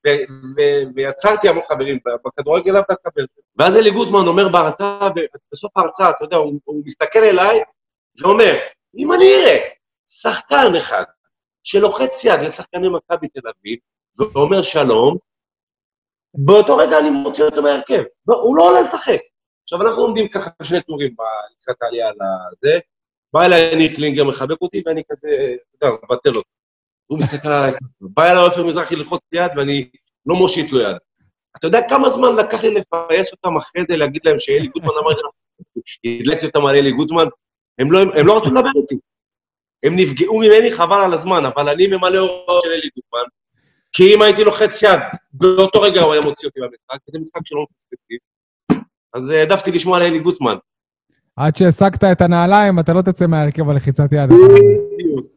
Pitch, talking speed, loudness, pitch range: 175 Hz, 160 wpm, -14 LUFS, 150-215 Hz